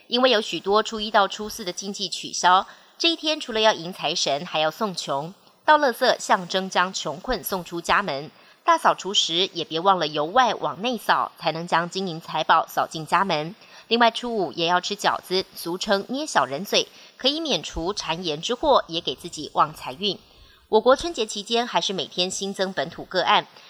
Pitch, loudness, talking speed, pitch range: 195 Hz, -23 LUFS, 280 characters per minute, 170-230 Hz